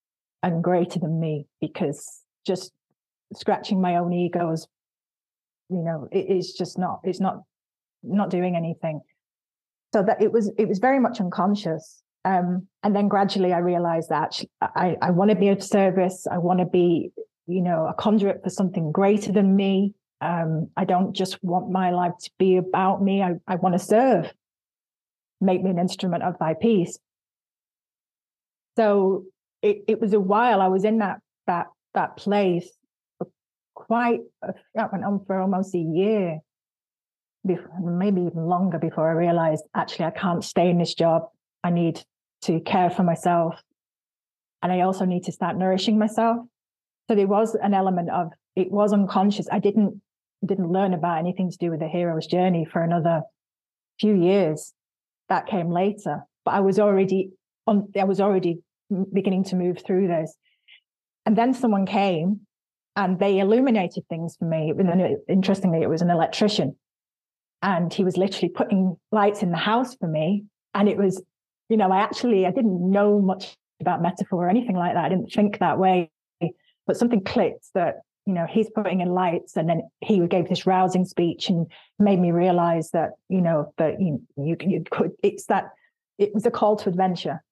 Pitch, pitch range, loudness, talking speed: 185 Hz, 175-200 Hz, -23 LUFS, 175 wpm